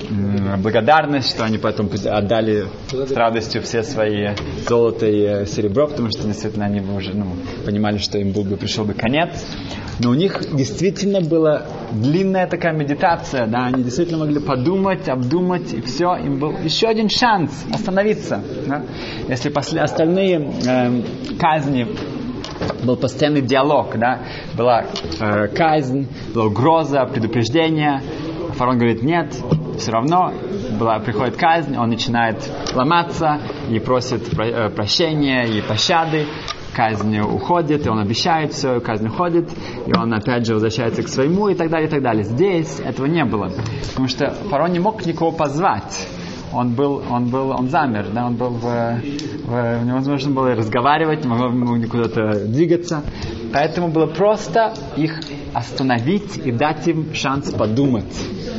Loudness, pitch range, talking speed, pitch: -19 LUFS, 115-155 Hz, 145 wpm, 130 Hz